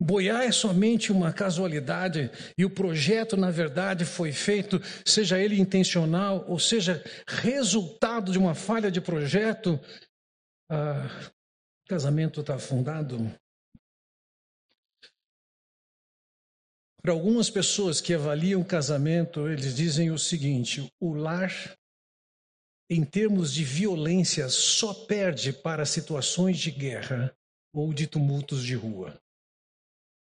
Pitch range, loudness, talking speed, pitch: 150-195 Hz, -27 LUFS, 110 wpm, 170 Hz